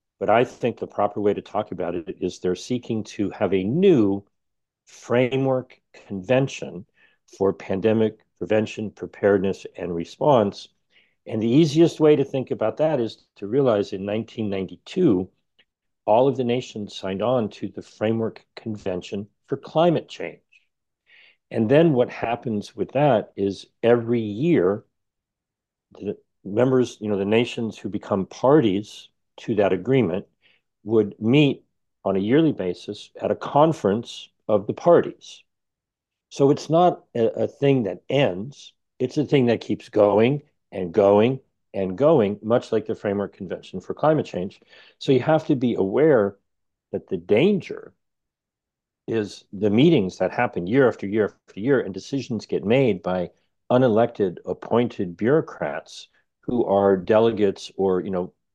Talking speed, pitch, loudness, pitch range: 145 wpm, 110 Hz, -22 LUFS, 100-125 Hz